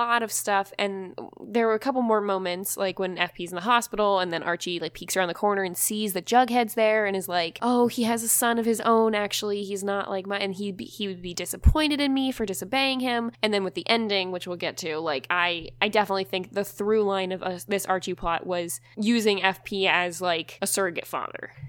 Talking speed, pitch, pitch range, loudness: 240 wpm, 200 Hz, 180-225 Hz, -25 LUFS